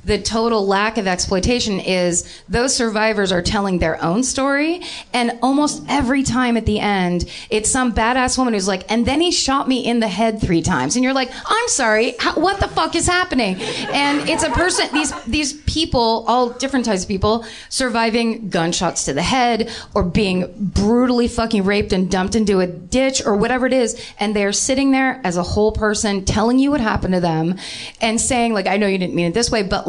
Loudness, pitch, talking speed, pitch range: -18 LUFS, 230 Hz, 205 wpm, 200-260 Hz